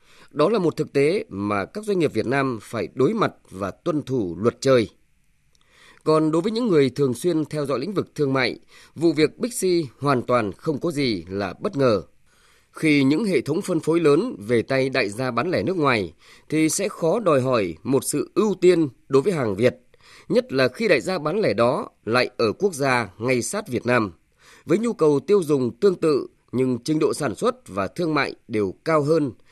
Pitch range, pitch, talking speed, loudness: 120-160 Hz, 140 Hz, 215 wpm, -22 LUFS